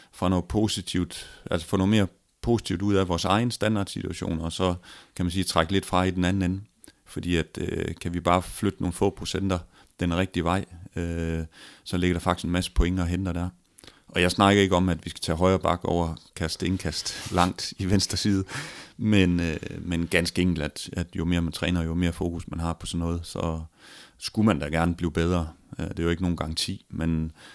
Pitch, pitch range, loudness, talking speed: 90 Hz, 85-95 Hz, -26 LUFS, 215 wpm